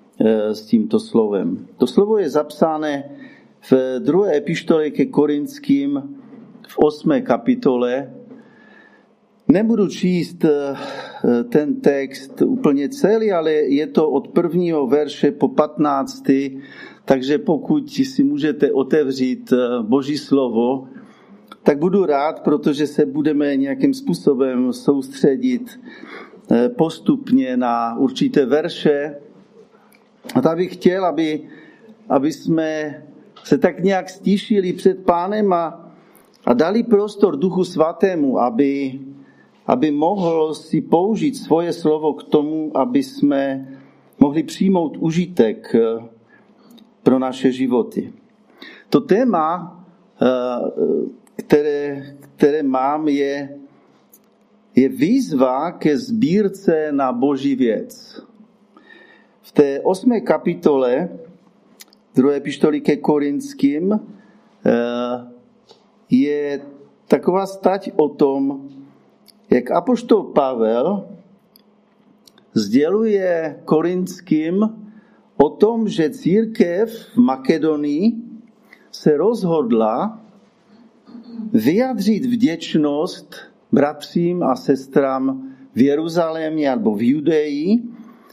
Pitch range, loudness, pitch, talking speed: 145-225 Hz, -18 LUFS, 175 Hz, 90 wpm